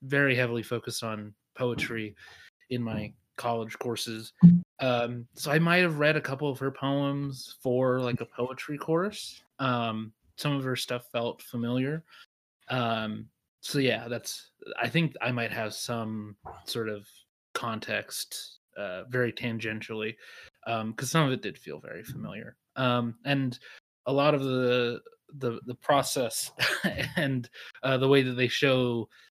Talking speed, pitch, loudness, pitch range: 150 wpm, 125 Hz, -29 LUFS, 115-140 Hz